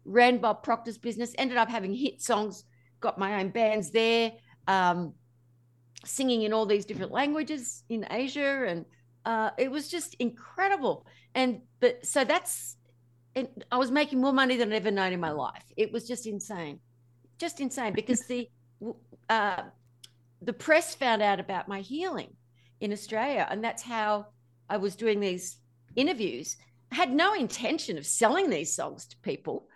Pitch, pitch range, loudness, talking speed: 220 Hz, 170-250 Hz, -29 LUFS, 165 wpm